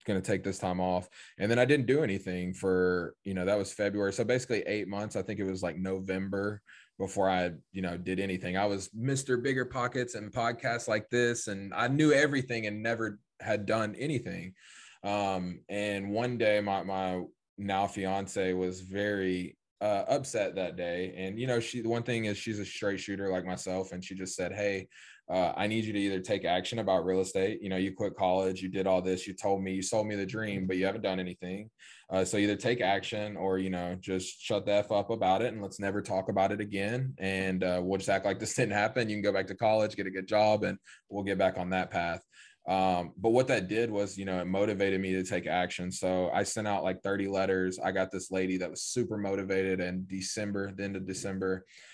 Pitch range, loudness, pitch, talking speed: 95-105 Hz, -32 LUFS, 100 Hz, 230 wpm